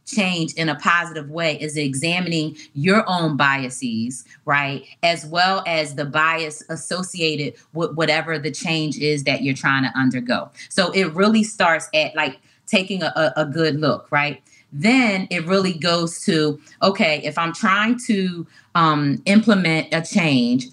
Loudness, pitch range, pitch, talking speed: -20 LUFS, 150-185 Hz, 160 Hz, 155 wpm